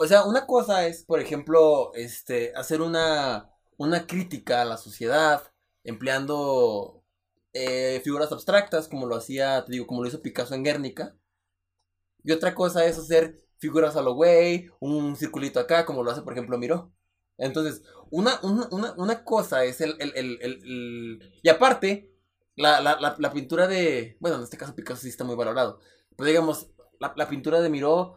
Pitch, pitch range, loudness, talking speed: 150 Hz, 125-165 Hz, -25 LUFS, 175 wpm